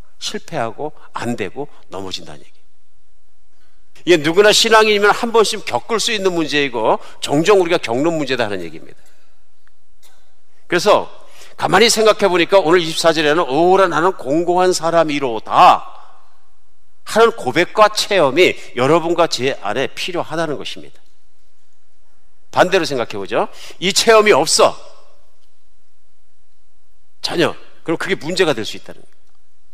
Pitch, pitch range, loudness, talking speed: 175 Hz, 150-205 Hz, -15 LUFS, 275 characters per minute